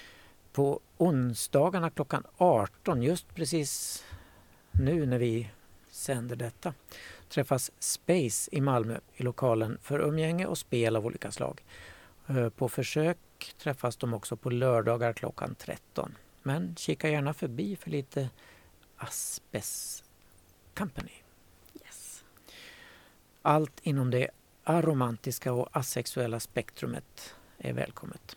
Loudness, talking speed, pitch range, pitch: -31 LUFS, 110 wpm, 115-150 Hz, 125 Hz